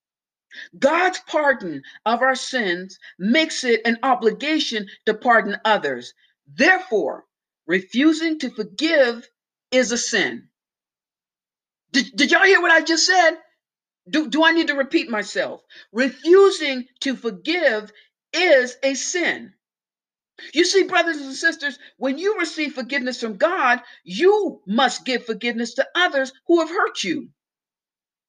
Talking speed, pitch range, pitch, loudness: 130 wpm, 235-325 Hz, 275 Hz, -19 LUFS